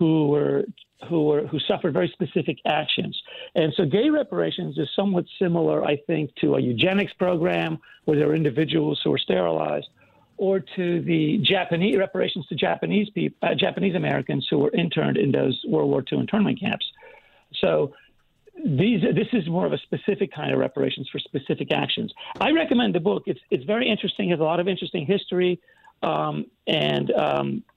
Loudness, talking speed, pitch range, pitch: -23 LUFS, 175 wpm, 155-205 Hz, 180 Hz